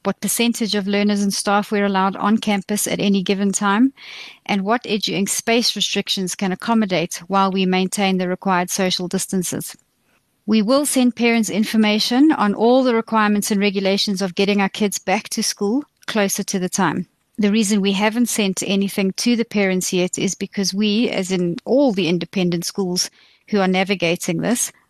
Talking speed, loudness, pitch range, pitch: 175 wpm, -19 LUFS, 190-215 Hz, 200 Hz